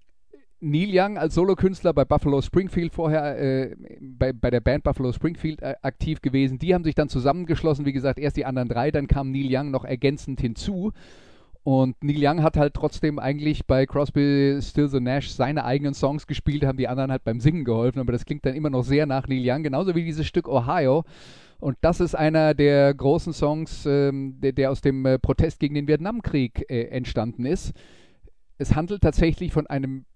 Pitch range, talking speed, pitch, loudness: 135-155 Hz, 195 wpm, 140 Hz, -23 LUFS